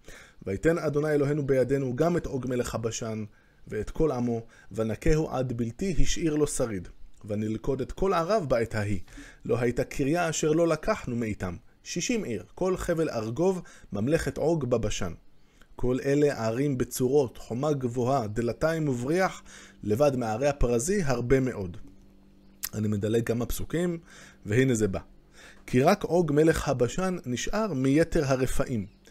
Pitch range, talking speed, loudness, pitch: 110-160 Hz, 140 wpm, -28 LUFS, 130 Hz